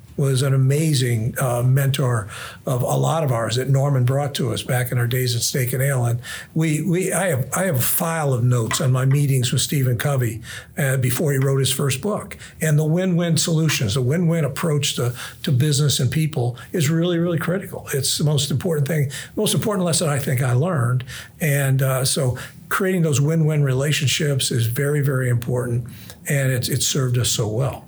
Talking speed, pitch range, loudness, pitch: 205 wpm, 125-155 Hz, -20 LUFS, 135 Hz